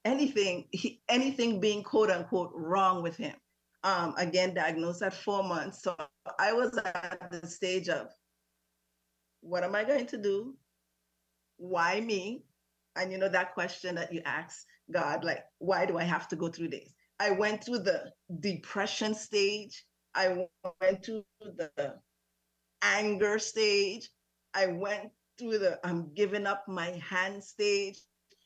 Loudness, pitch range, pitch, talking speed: -32 LUFS, 170-210 Hz, 185 Hz, 150 wpm